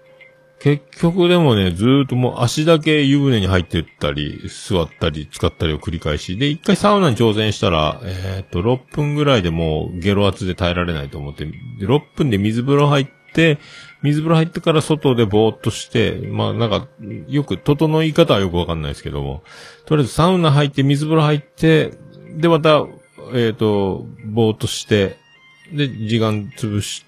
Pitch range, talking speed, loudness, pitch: 95-155 Hz, 350 characters per minute, -17 LUFS, 125 Hz